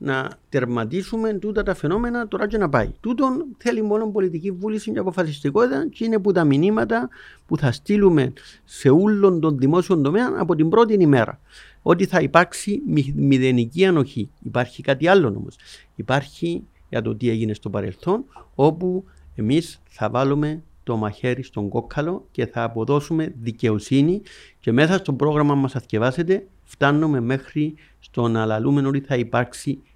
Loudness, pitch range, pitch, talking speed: -21 LUFS, 125-190 Hz, 150 Hz, 150 wpm